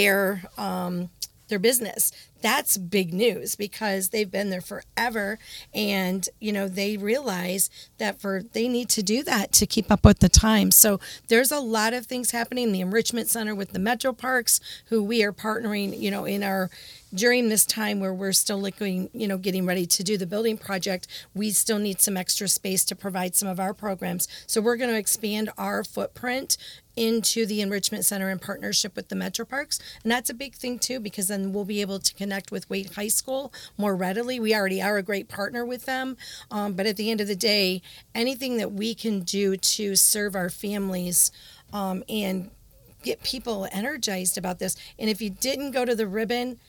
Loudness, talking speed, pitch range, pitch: -24 LUFS, 200 wpm, 195-230 Hz, 205 Hz